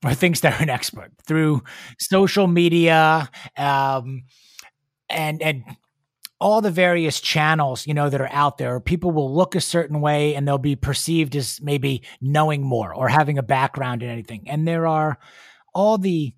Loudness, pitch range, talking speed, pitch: -20 LUFS, 135-160 Hz, 170 wpm, 150 Hz